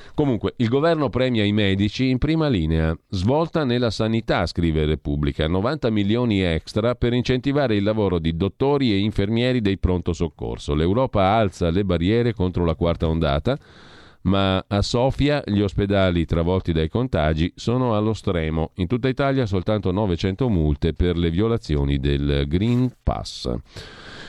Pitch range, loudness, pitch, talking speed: 85-120 Hz, -21 LUFS, 100 Hz, 145 wpm